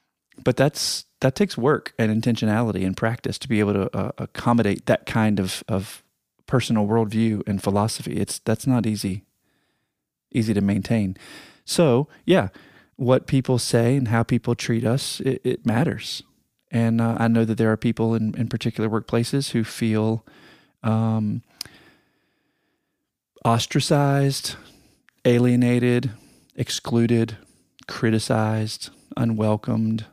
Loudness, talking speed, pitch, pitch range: -22 LUFS, 125 wpm, 115 Hz, 110-120 Hz